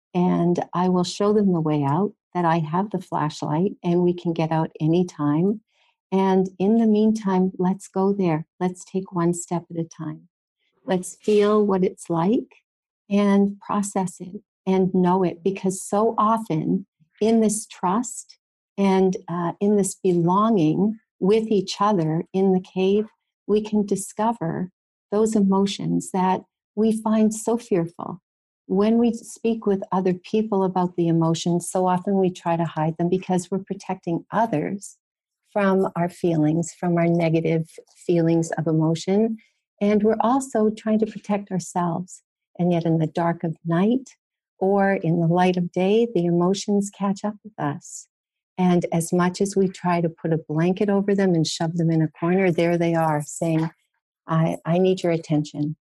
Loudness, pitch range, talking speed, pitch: -22 LUFS, 170-205 Hz, 165 wpm, 185 Hz